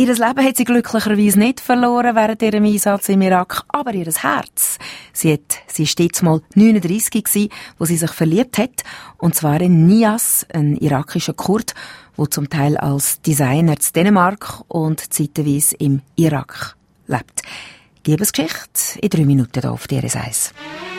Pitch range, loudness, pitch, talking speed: 155-220 Hz, -16 LUFS, 180 Hz, 165 wpm